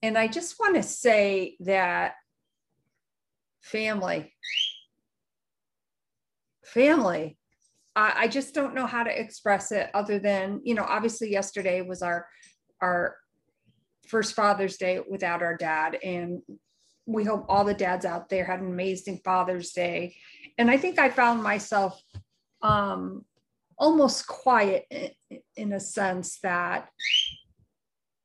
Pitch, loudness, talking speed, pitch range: 200 Hz, -26 LUFS, 125 wpm, 185-235 Hz